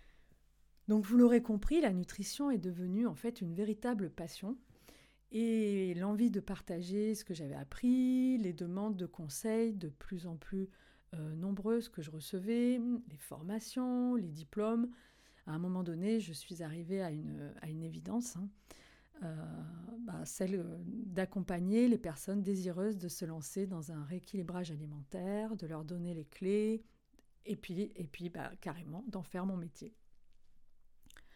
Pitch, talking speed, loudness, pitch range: 195 Hz, 155 wpm, -38 LUFS, 170-220 Hz